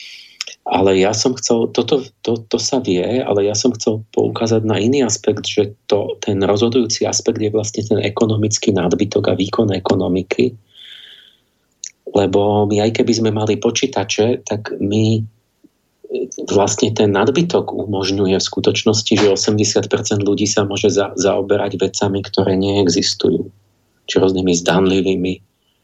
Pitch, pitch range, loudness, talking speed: 105 Hz, 100-115 Hz, -16 LUFS, 135 wpm